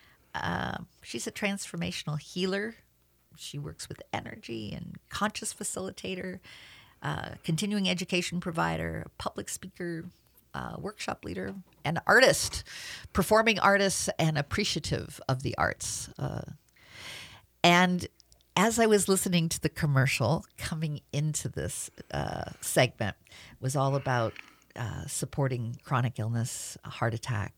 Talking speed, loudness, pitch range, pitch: 120 wpm, -30 LUFS, 115-185 Hz, 150 Hz